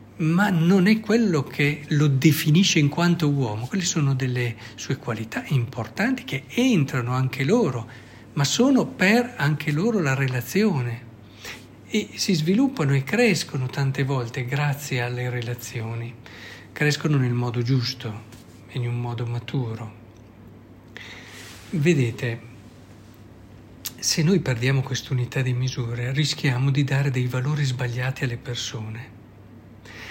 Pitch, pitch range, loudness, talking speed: 130 Hz, 115-150 Hz, -23 LUFS, 120 wpm